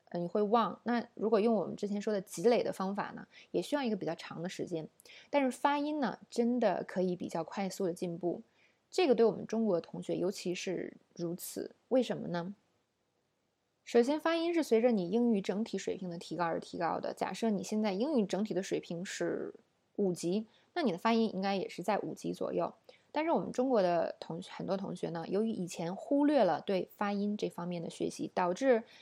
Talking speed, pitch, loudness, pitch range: 305 characters per minute, 210 Hz, -34 LUFS, 180-235 Hz